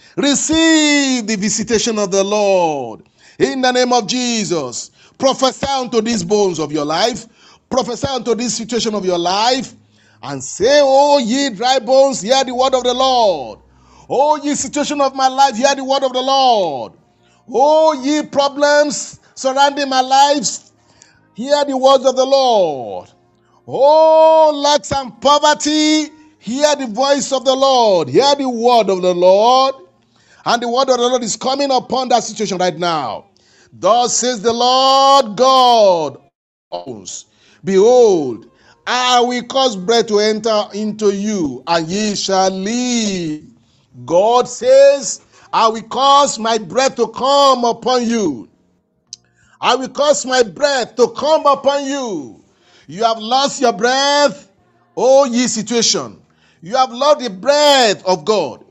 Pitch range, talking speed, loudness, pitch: 220-275 Hz, 145 wpm, -14 LUFS, 255 Hz